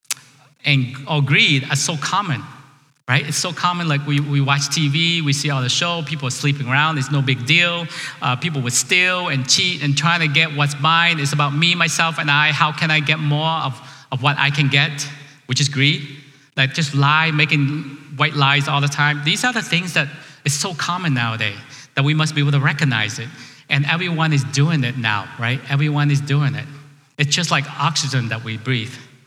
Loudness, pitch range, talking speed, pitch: -17 LUFS, 140-160 Hz, 215 wpm, 145 Hz